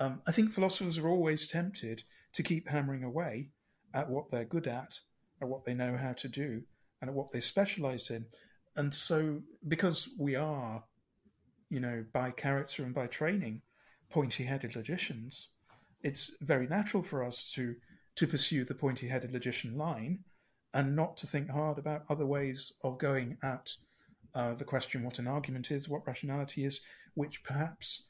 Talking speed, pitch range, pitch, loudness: 170 wpm, 125-155 Hz, 140 Hz, -33 LUFS